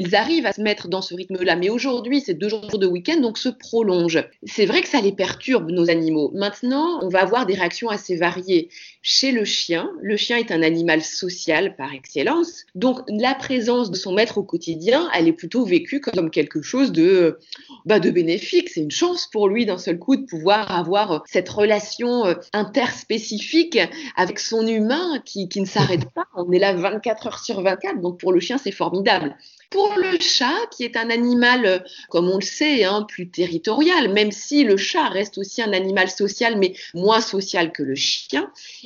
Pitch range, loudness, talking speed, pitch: 185-255 Hz, -20 LUFS, 200 wpm, 210 Hz